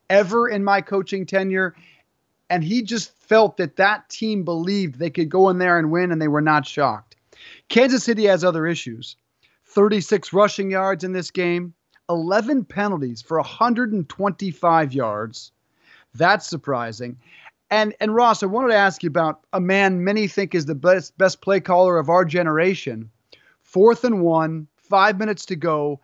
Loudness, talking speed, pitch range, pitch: -20 LUFS, 165 wpm, 160-205 Hz, 185 Hz